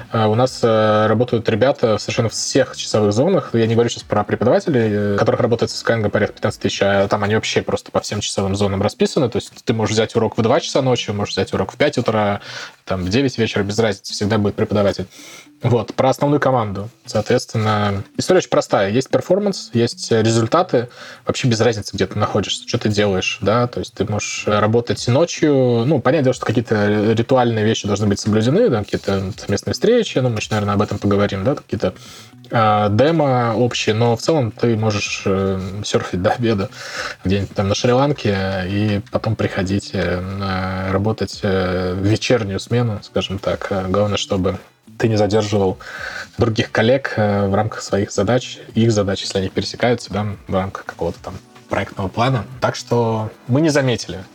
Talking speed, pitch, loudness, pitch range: 175 wpm, 110 Hz, -18 LUFS, 100-120 Hz